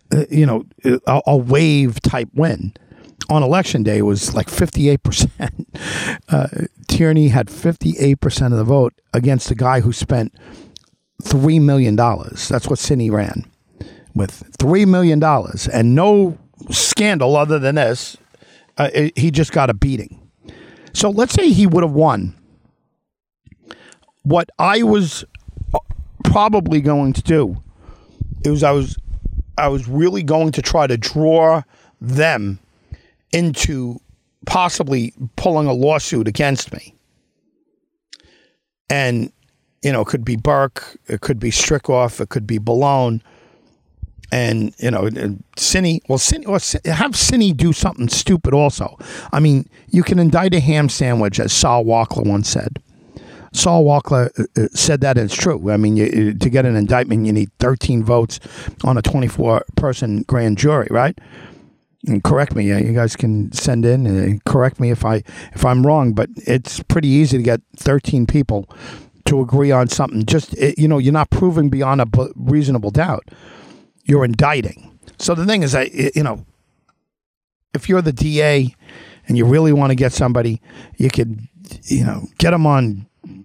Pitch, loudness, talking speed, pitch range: 130 Hz, -16 LUFS, 155 wpm, 115-150 Hz